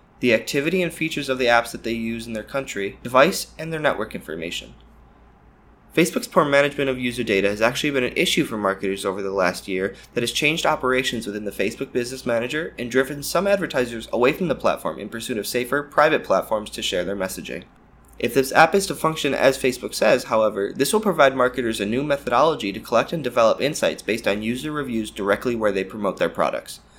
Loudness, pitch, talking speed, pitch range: -22 LUFS, 125 Hz, 210 wpm, 110-145 Hz